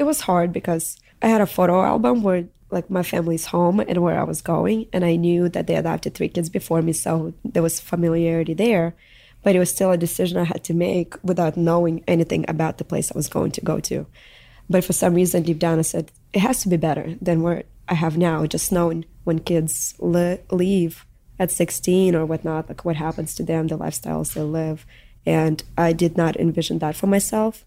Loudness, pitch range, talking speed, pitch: -21 LUFS, 160-180 Hz, 220 wpm, 170 Hz